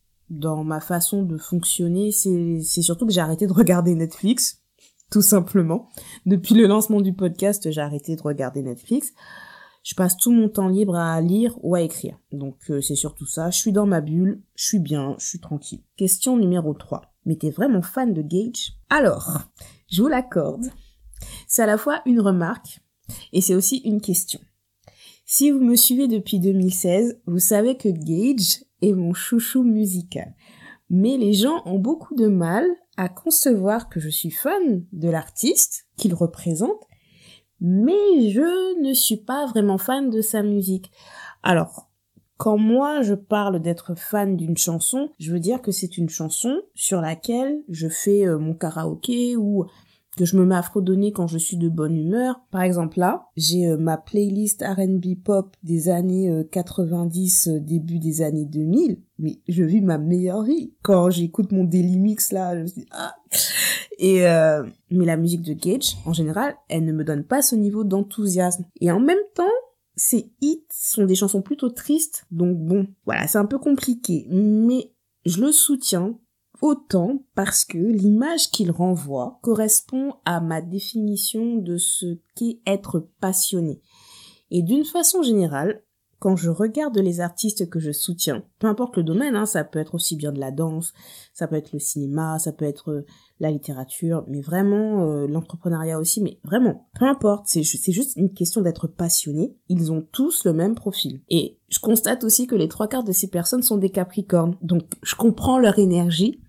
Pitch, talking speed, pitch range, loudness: 190 Hz, 180 wpm, 170-225 Hz, -21 LUFS